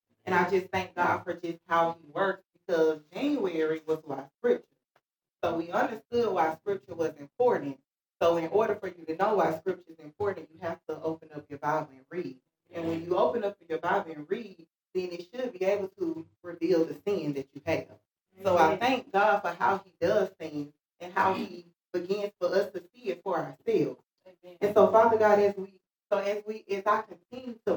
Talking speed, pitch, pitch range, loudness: 205 wpm, 180 Hz, 160-205 Hz, -29 LUFS